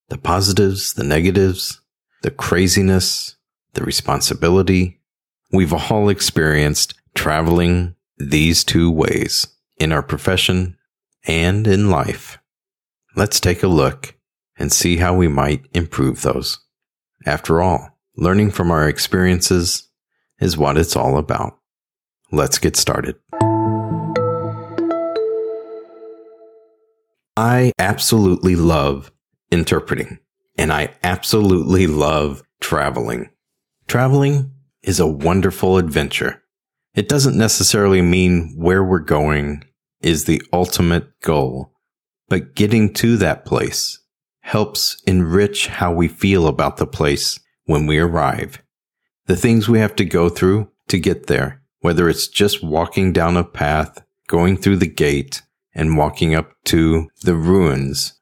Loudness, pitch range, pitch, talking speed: -17 LUFS, 80-105 Hz, 90 Hz, 115 wpm